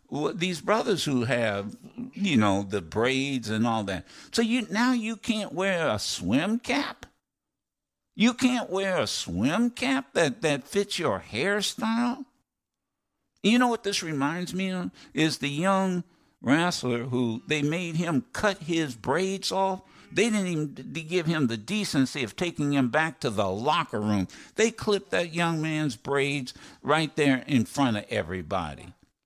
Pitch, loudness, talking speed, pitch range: 170 Hz, -27 LUFS, 160 wpm, 135-210 Hz